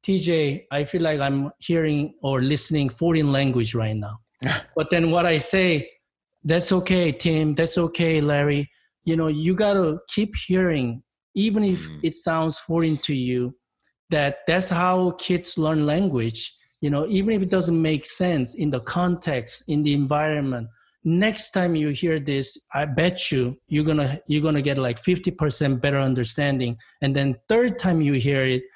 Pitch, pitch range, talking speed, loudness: 155 Hz, 140-175 Hz, 165 wpm, -22 LUFS